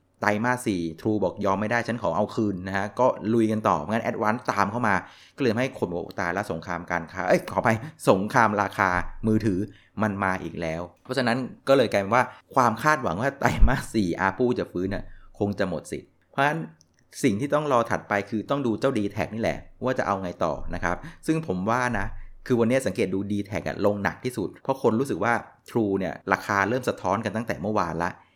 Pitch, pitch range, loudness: 105 Hz, 95-115 Hz, -25 LUFS